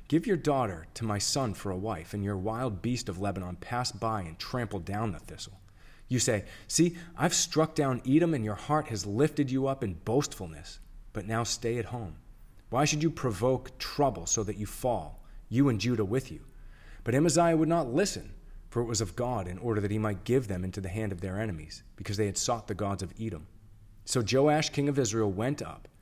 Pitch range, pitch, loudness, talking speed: 100-135 Hz, 115 Hz, -30 LUFS, 220 wpm